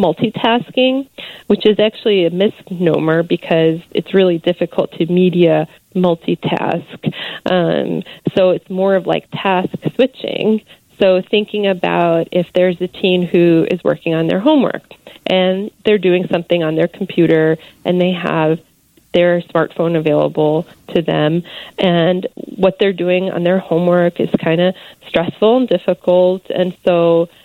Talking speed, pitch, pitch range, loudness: 140 wpm, 180 Hz, 170-195 Hz, -15 LUFS